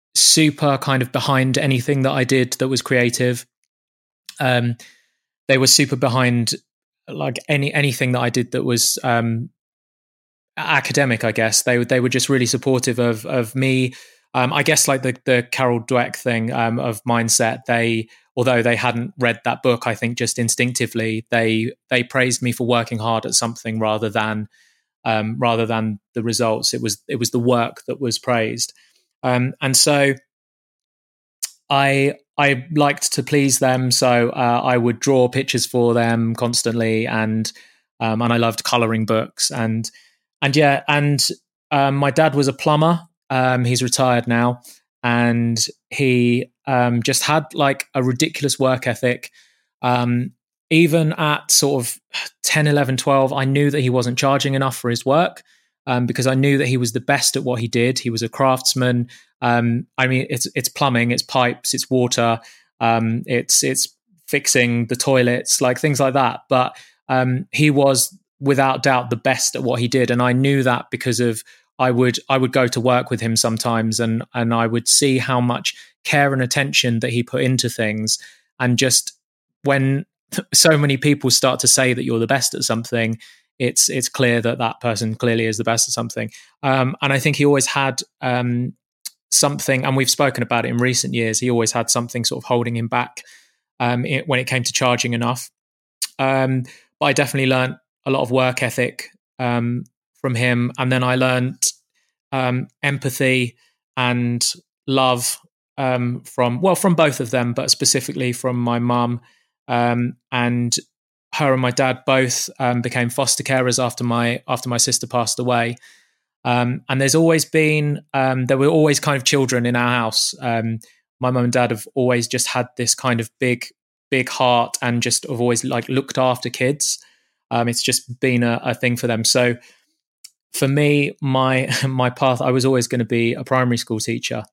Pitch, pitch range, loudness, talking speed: 125 Hz, 120-135 Hz, -18 LUFS, 180 wpm